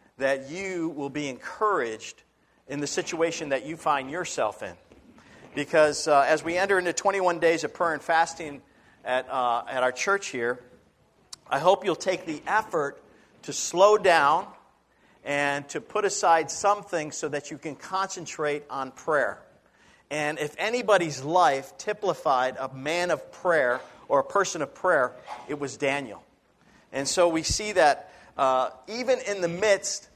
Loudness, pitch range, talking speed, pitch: -26 LUFS, 140-185 Hz, 155 wpm, 160 Hz